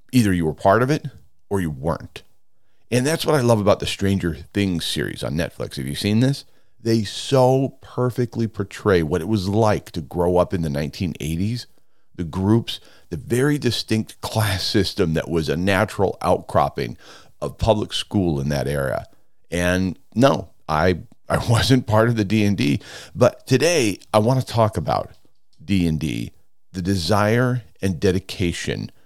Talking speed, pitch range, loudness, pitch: 160 wpm, 90-115 Hz, -21 LUFS, 100 Hz